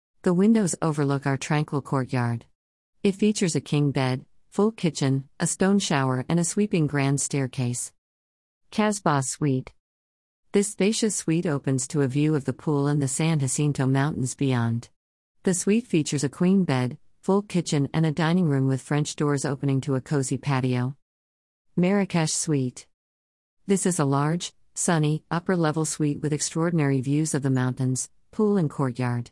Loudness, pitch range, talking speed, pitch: -25 LUFS, 130-170 Hz, 160 wpm, 145 Hz